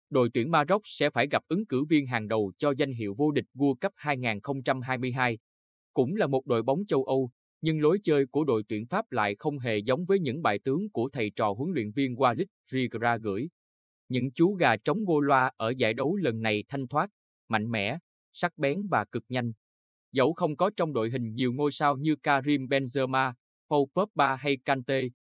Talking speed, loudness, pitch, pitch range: 205 wpm, -28 LUFS, 135 Hz, 115-145 Hz